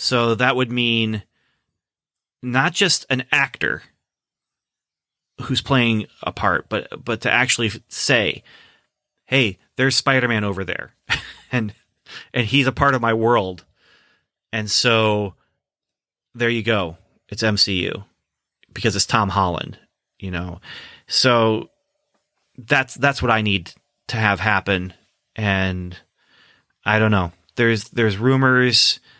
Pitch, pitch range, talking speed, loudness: 115 Hz, 100-130 Hz, 120 wpm, -19 LUFS